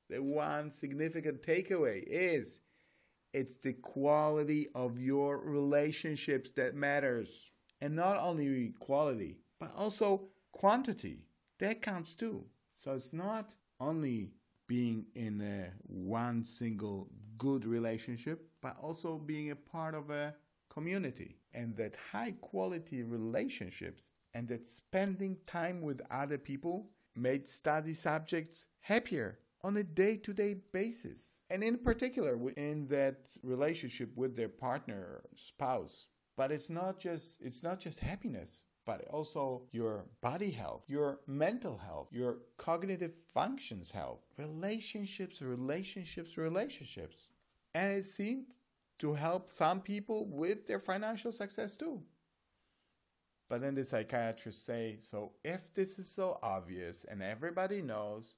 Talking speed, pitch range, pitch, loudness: 125 wpm, 120-185 Hz, 150 Hz, -38 LUFS